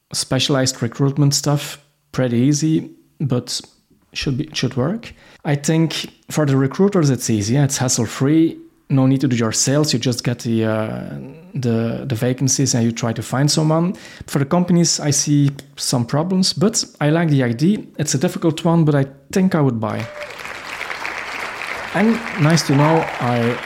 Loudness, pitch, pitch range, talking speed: -18 LUFS, 145 Hz, 125-160 Hz, 165 wpm